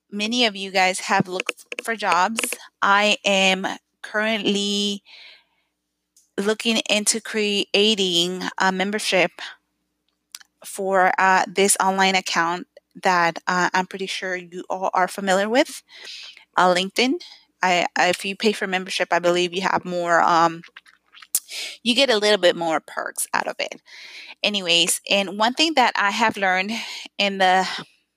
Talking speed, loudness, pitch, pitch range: 140 wpm, -20 LUFS, 195 Hz, 180-215 Hz